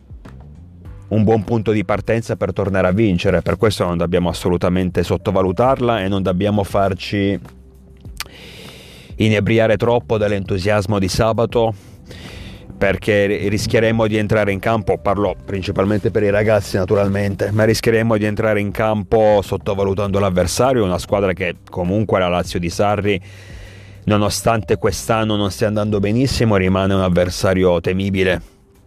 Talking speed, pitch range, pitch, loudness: 130 wpm, 95-110 Hz, 100 Hz, -17 LUFS